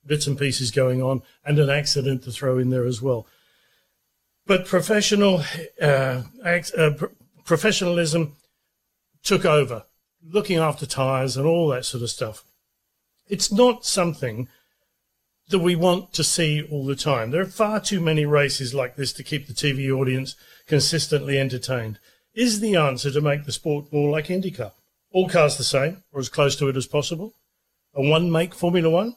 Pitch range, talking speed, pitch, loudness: 135-175 Hz, 170 wpm, 150 Hz, -22 LUFS